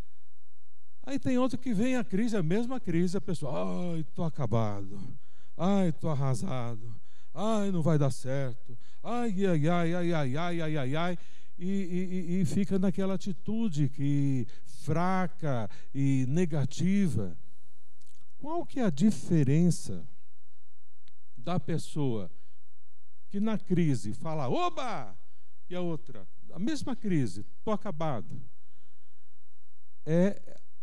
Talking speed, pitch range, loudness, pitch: 120 wpm, 140-195 Hz, -31 LUFS, 170 Hz